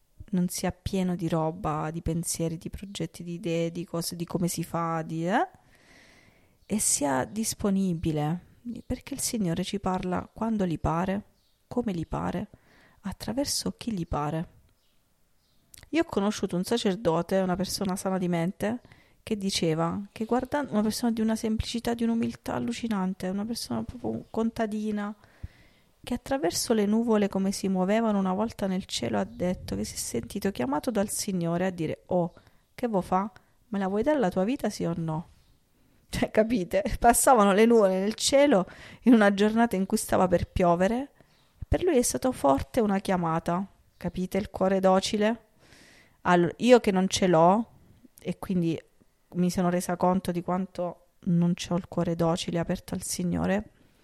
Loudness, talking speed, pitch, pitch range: -27 LUFS, 165 wpm, 190 Hz, 170-220 Hz